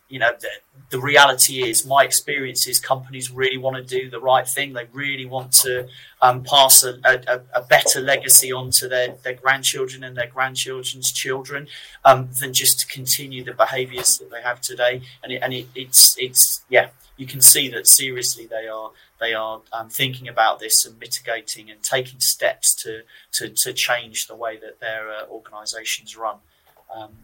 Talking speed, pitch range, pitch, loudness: 185 wpm, 120-135 Hz, 130 Hz, -17 LUFS